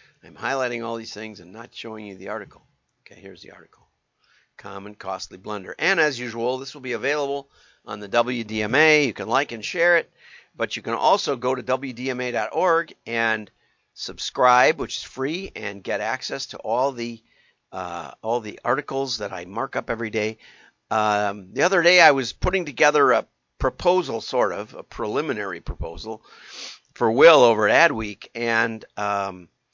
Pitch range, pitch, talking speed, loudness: 105-135 Hz, 115 Hz, 170 wpm, -22 LUFS